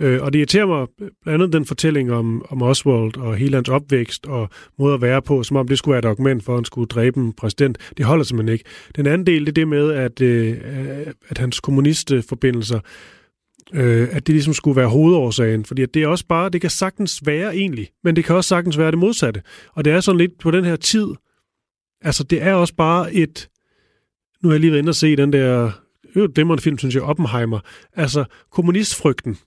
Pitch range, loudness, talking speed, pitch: 125-165 Hz, -18 LUFS, 225 wpm, 145 Hz